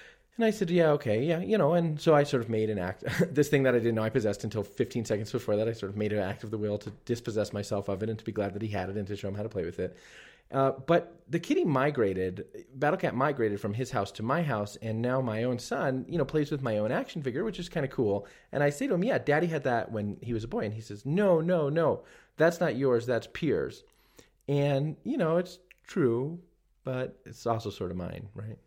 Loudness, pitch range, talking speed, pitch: -30 LUFS, 105-150 Hz, 270 wpm, 120 Hz